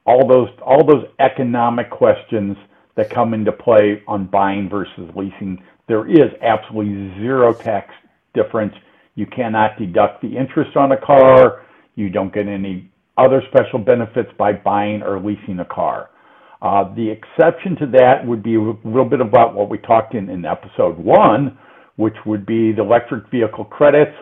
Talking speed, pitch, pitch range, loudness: 165 wpm, 110 Hz, 105-130 Hz, -15 LUFS